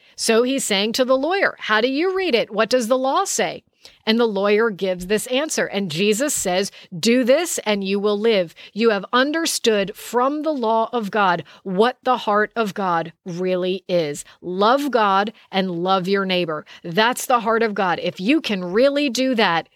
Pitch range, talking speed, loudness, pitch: 190-250 Hz, 190 wpm, -20 LUFS, 215 Hz